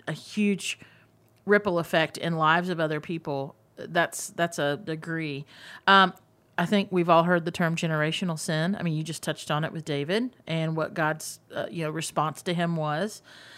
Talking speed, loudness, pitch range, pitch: 185 wpm, -27 LUFS, 155-175 Hz, 160 Hz